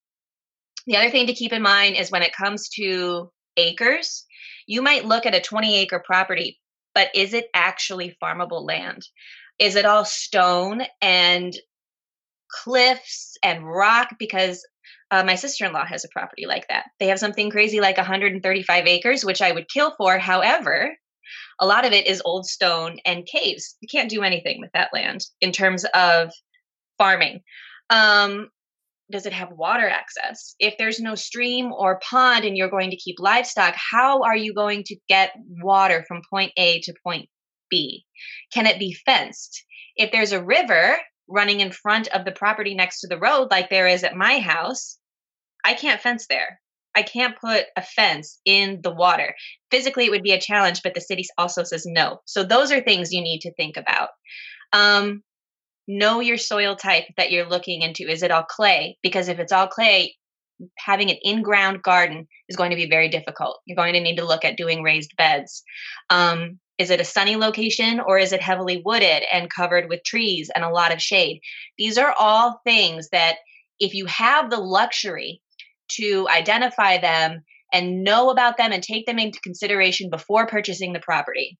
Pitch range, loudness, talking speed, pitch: 180-220 Hz, -19 LUFS, 185 wpm, 195 Hz